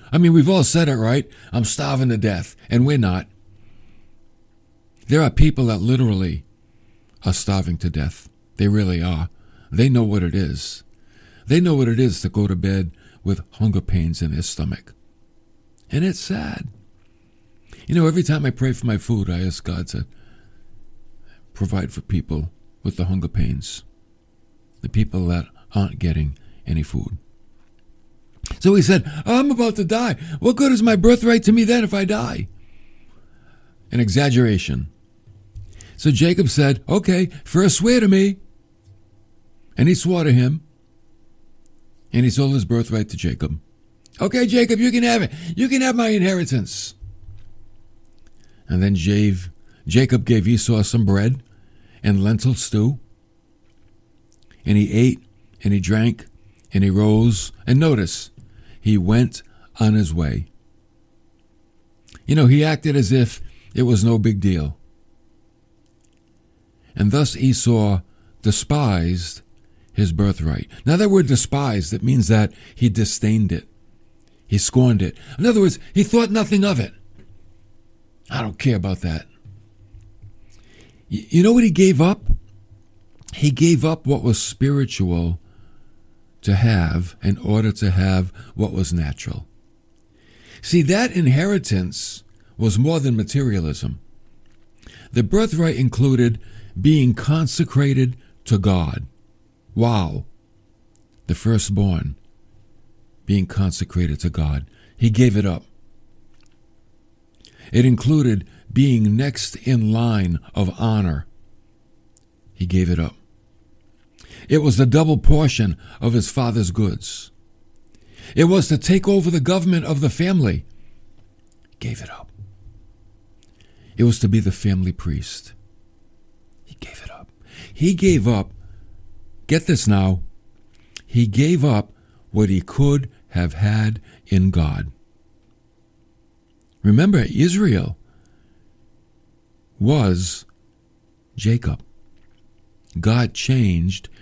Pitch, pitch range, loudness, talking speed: 110 Hz, 100-130 Hz, -19 LUFS, 130 wpm